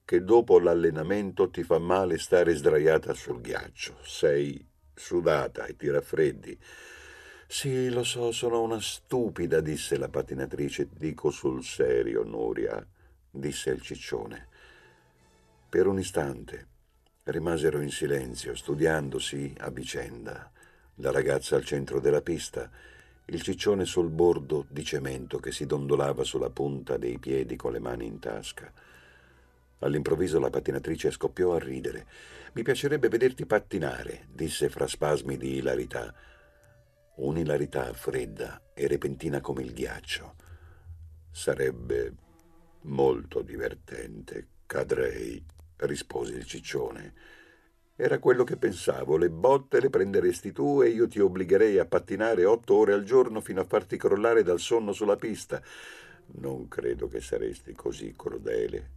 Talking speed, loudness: 130 wpm, -28 LUFS